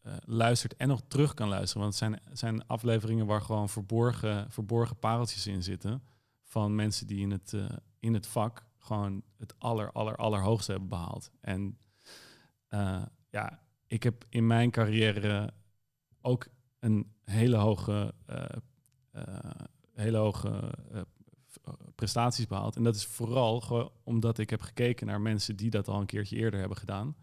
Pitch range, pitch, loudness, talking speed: 105-120 Hz, 110 Hz, -32 LUFS, 160 wpm